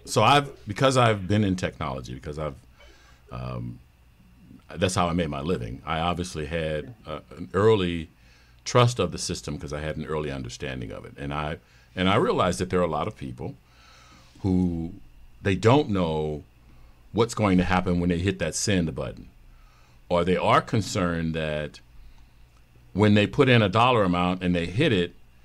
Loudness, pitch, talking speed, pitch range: -25 LUFS, 85 Hz, 180 wpm, 60-95 Hz